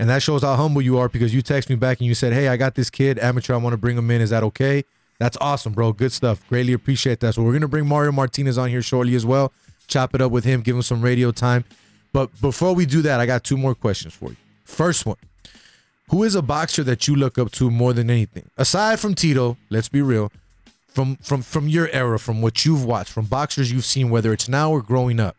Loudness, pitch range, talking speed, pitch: -20 LUFS, 120-140 Hz, 260 wpm, 125 Hz